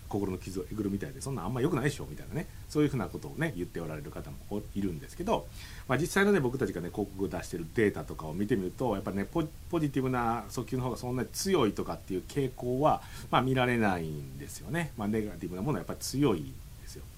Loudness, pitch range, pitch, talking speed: -32 LUFS, 90-125 Hz, 105 Hz, 515 characters per minute